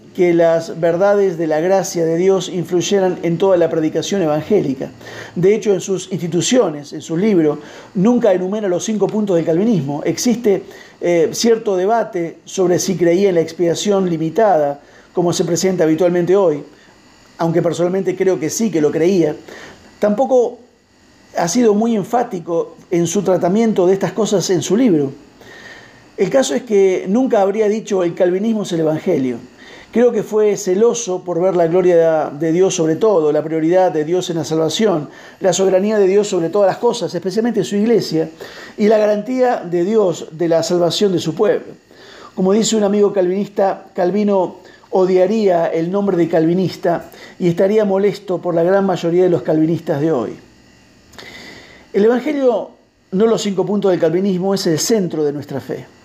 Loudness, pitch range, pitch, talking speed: -16 LUFS, 170-205 Hz, 185 Hz, 170 wpm